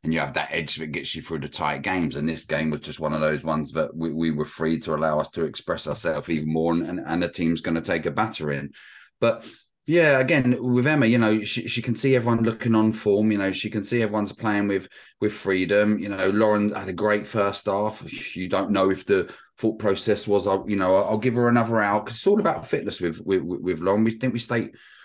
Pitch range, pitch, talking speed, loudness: 85-115 Hz, 100 Hz, 250 wpm, -24 LUFS